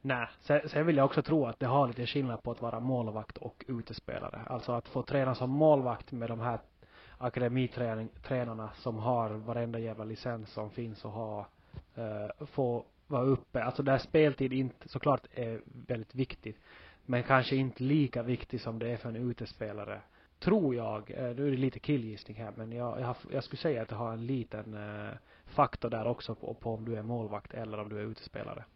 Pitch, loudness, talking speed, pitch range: 120 Hz, -34 LUFS, 200 wpm, 110-130 Hz